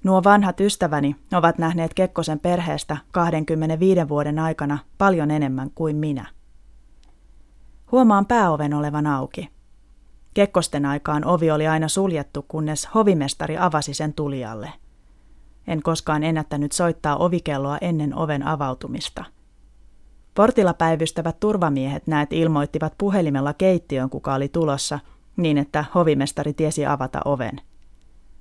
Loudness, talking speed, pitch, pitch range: -21 LUFS, 110 wpm, 150 Hz, 140-170 Hz